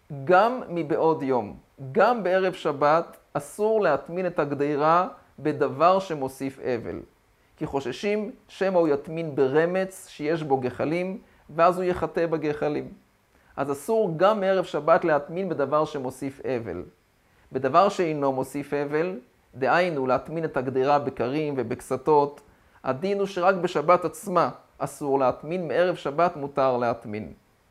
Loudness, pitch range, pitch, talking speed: -25 LUFS, 135-180 Hz, 155 Hz, 120 wpm